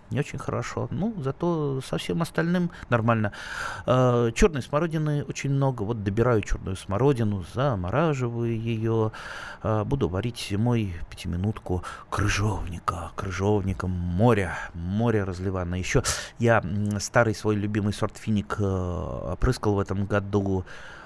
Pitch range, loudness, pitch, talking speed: 100-125 Hz, -26 LUFS, 110 Hz, 120 wpm